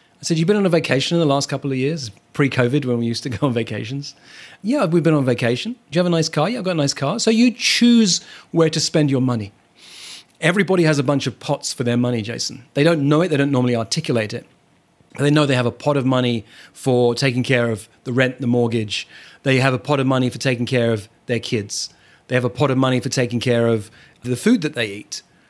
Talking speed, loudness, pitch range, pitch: 255 wpm, -19 LUFS, 120-155 Hz, 135 Hz